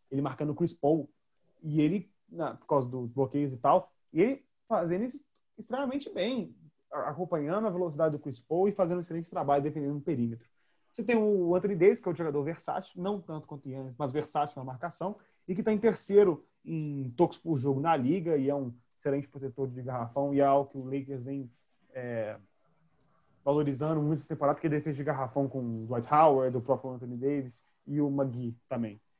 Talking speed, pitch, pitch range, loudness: 205 wpm, 150 Hz, 135-175 Hz, -31 LUFS